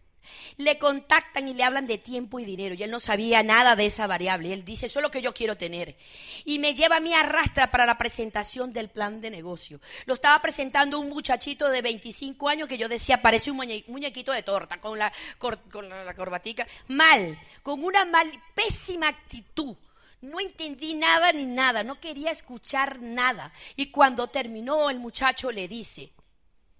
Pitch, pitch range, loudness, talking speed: 250 Hz, 215-290 Hz, -24 LUFS, 185 wpm